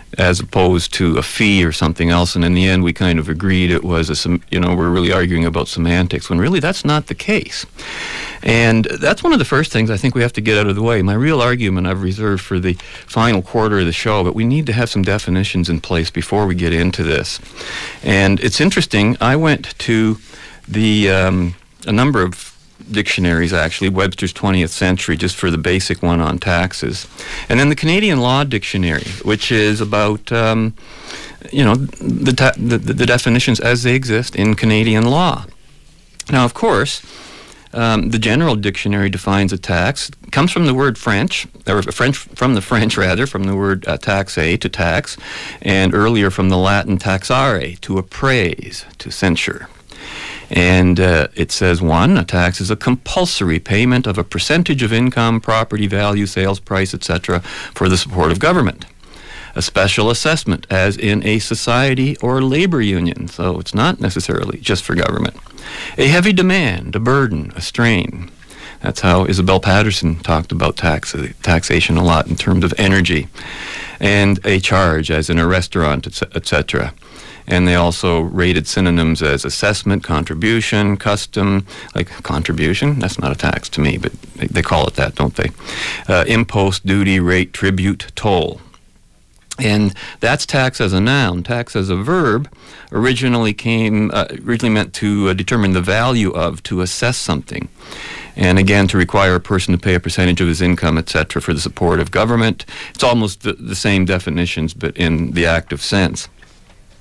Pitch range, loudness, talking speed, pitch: 90-115 Hz, -15 LUFS, 180 wpm, 100 Hz